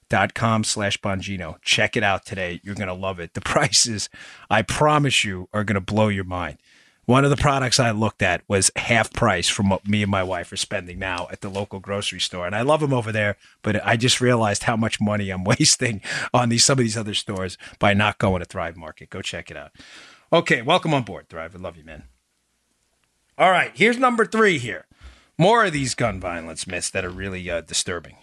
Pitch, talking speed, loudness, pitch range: 105 Hz, 220 wpm, -21 LUFS, 95-120 Hz